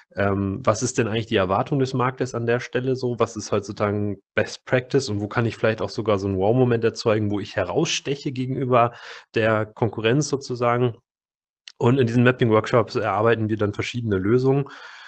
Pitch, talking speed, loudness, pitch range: 115 Hz, 175 wpm, -22 LUFS, 105-125 Hz